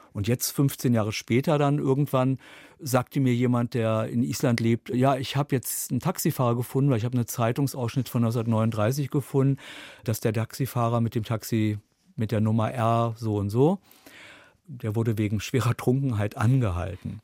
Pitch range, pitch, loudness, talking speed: 115-135 Hz, 120 Hz, -26 LUFS, 165 wpm